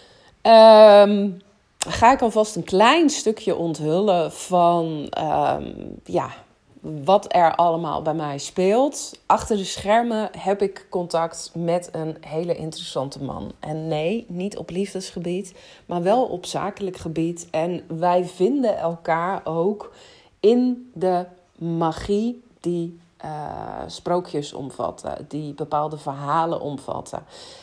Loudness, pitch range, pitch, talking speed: -21 LUFS, 165-205 Hz, 175 Hz, 115 wpm